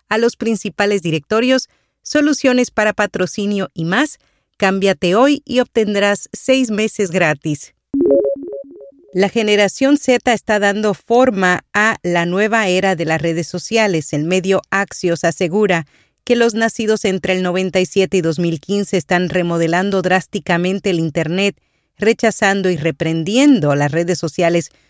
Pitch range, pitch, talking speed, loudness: 170-220 Hz, 195 Hz, 130 wpm, -16 LUFS